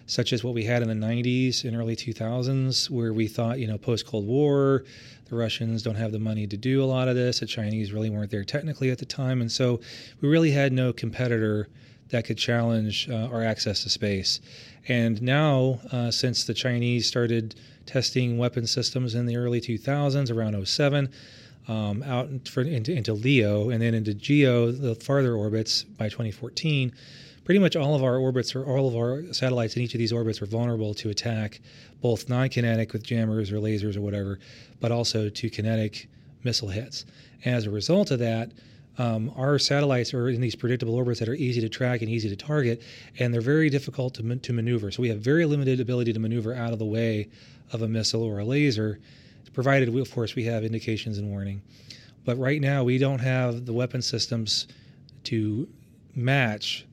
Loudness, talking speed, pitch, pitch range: -26 LUFS, 195 wpm, 120 Hz, 115-130 Hz